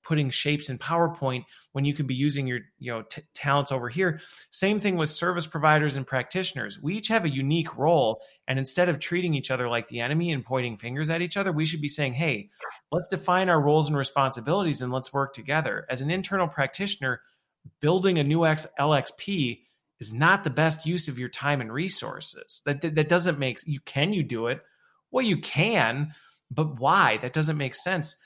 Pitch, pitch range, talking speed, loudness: 150 Hz, 135-170 Hz, 205 wpm, -26 LUFS